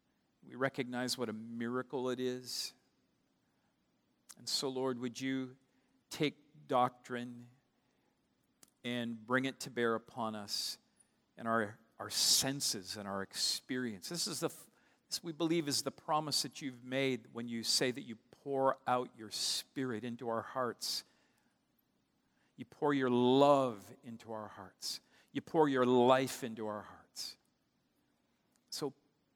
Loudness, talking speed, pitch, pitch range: -36 LUFS, 135 wpm, 125 Hz, 115-135 Hz